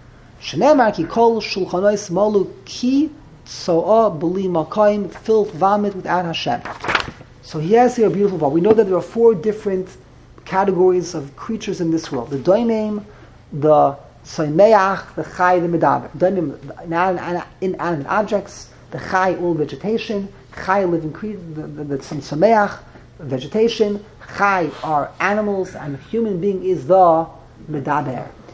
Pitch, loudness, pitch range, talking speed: 185 Hz, -18 LUFS, 155-205 Hz, 135 wpm